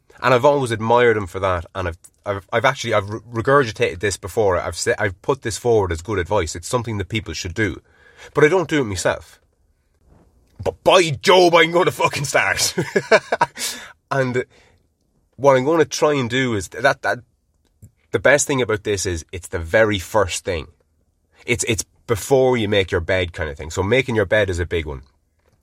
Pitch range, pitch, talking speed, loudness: 85-125 Hz, 105 Hz, 200 wpm, -19 LUFS